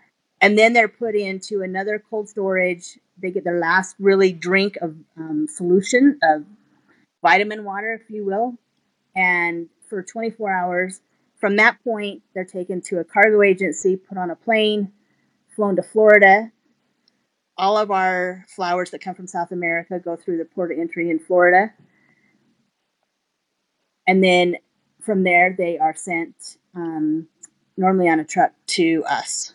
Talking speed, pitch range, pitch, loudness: 150 wpm, 180-210 Hz, 190 Hz, -19 LUFS